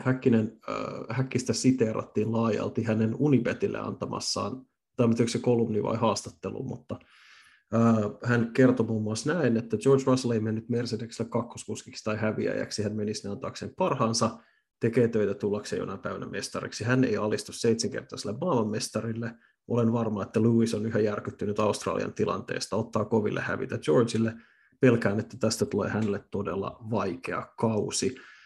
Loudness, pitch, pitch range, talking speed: -28 LUFS, 115 Hz, 110-120 Hz, 135 wpm